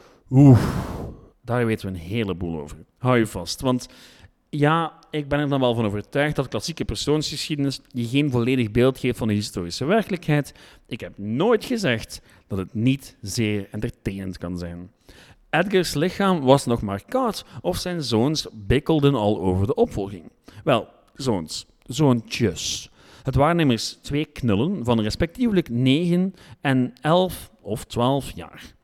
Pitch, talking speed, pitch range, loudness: 125 Hz, 150 wpm, 105-145 Hz, -23 LUFS